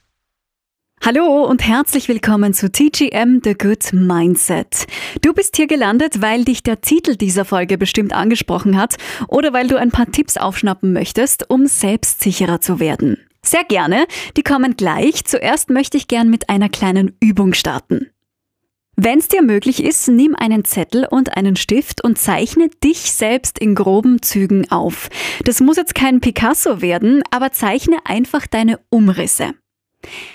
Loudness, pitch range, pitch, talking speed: -14 LUFS, 200-280 Hz, 235 Hz, 155 wpm